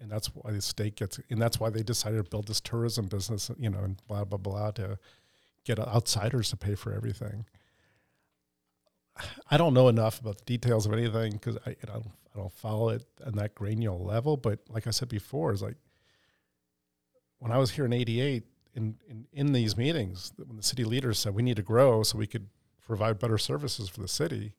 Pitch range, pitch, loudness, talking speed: 105-120 Hz, 110 Hz, -30 LUFS, 210 wpm